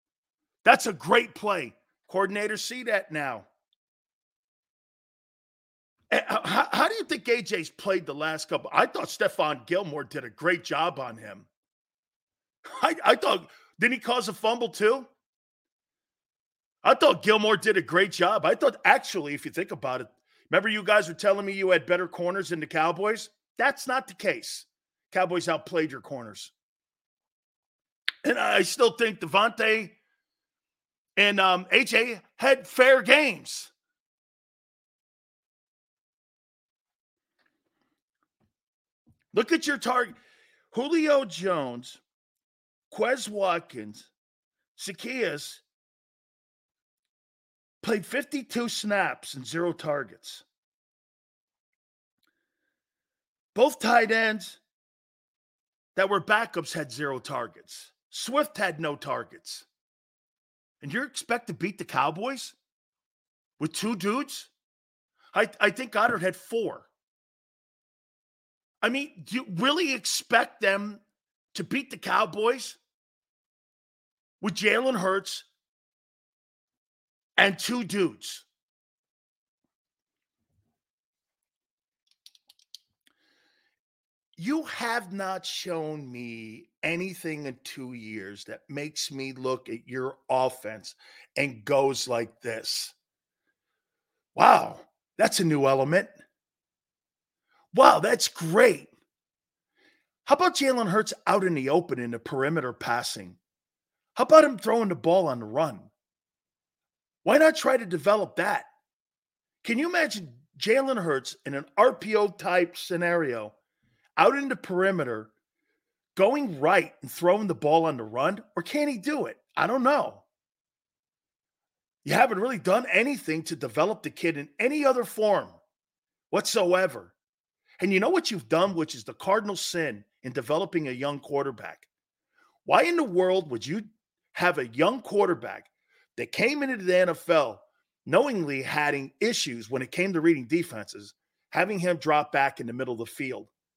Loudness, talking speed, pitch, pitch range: -26 LUFS, 125 wpm, 195 Hz, 155-240 Hz